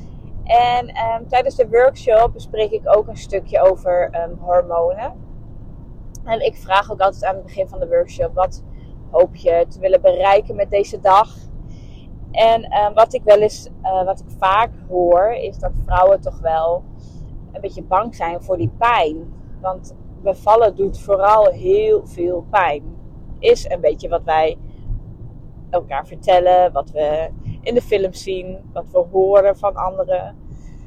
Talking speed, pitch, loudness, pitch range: 155 wpm, 190 Hz, -17 LUFS, 170-225 Hz